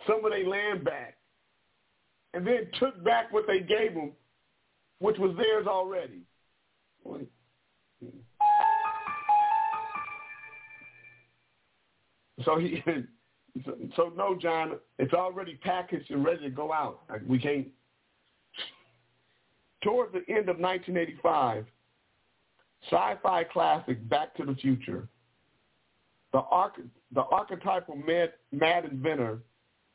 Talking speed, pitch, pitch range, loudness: 100 wpm, 175 Hz, 140-215 Hz, -29 LUFS